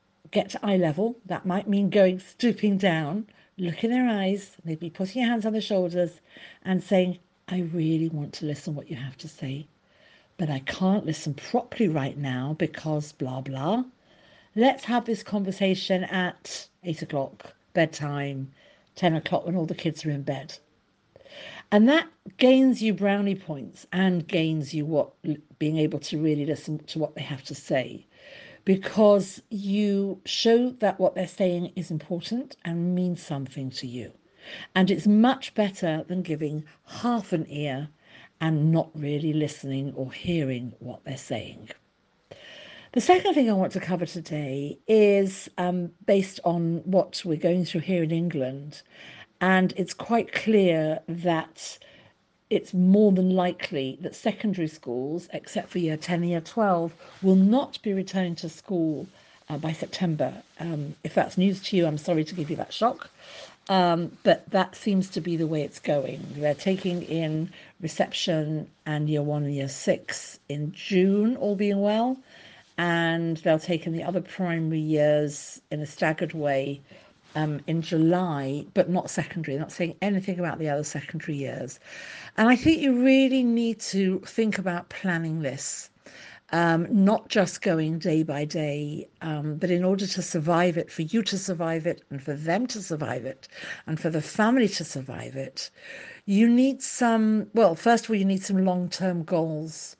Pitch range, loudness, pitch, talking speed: 155-195 Hz, -26 LUFS, 175 Hz, 170 wpm